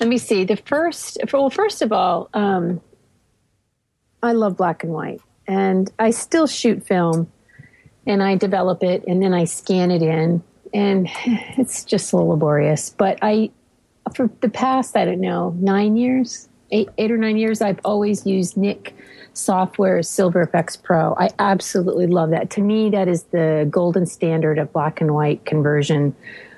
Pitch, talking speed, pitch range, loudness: 190 Hz, 170 wpm, 170-215 Hz, -19 LUFS